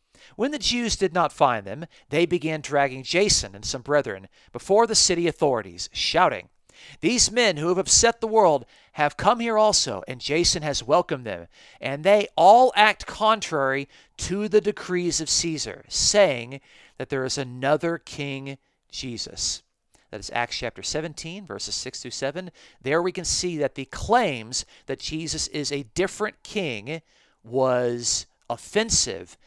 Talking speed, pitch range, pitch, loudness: 155 wpm, 135-190 Hz, 155 Hz, -23 LUFS